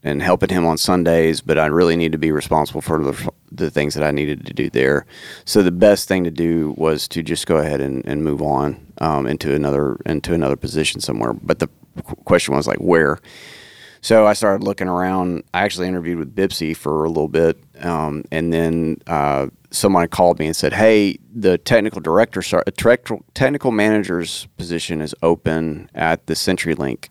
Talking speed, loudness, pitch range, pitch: 190 wpm, -18 LUFS, 75-90 Hz, 80 Hz